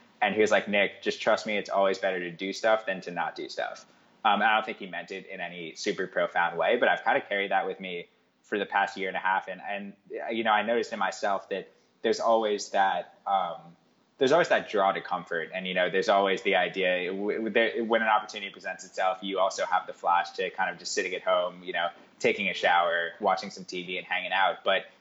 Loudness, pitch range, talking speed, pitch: -28 LUFS, 90-100 Hz, 240 wpm, 95 Hz